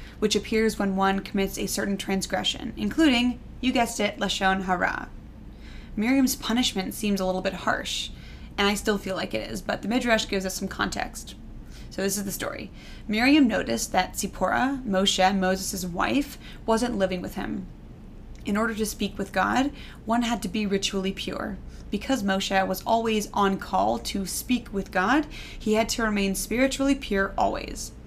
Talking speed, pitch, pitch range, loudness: 170 wpm, 200 Hz, 195-230 Hz, -26 LUFS